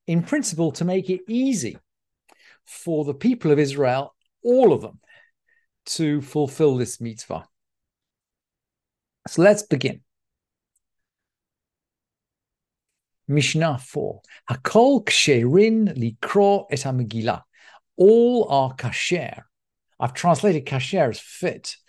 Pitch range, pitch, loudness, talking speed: 135-210 Hz, 160 Hz, -21 LUFS, 90 wpm